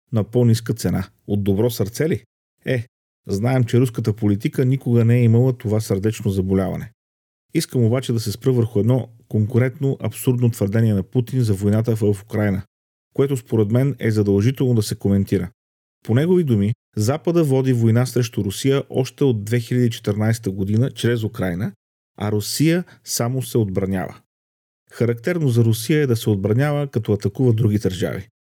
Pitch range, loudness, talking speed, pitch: 100-130 Hz, -20 LUFS, 155 wpm, 115 Hz